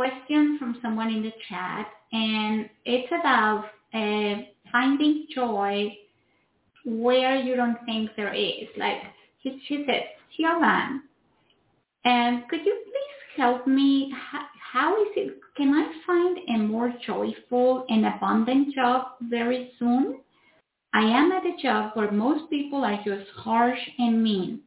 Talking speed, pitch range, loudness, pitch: 135 wpm, 220-275 Hz, -25 LUFS, 245 Hz